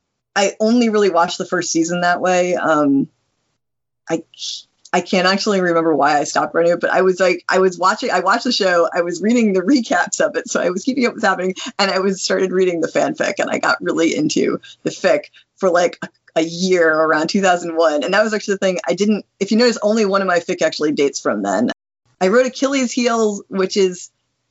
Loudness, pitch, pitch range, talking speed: -17 LUFS, 185 Hz, 170-210 Hz, 225 wpm